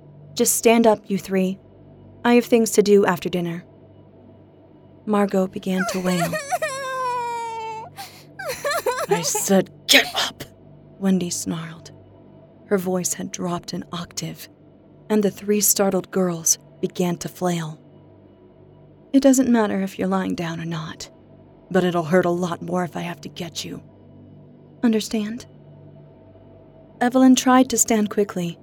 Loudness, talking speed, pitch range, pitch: -21 LUFS, 130 wpm, 175-225 Hz, 190 Hz